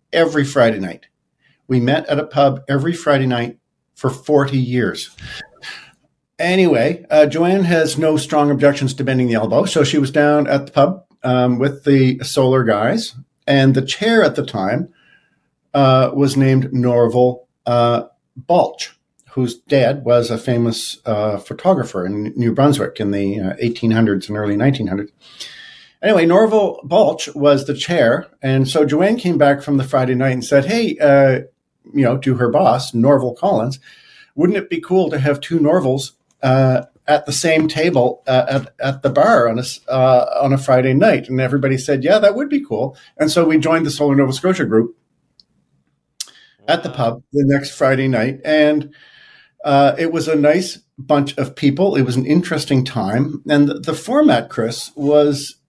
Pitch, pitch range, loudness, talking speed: 140 Hz, 125-155 Hz, -16 LUFS, 175 wpm